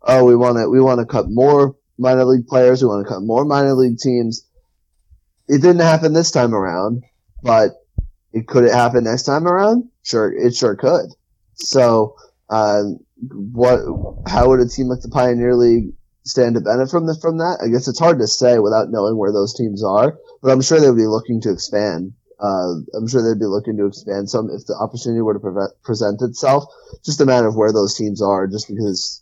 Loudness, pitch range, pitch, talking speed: -16 LUFS, 105-130 Hz, 120 Hz, 215 wpm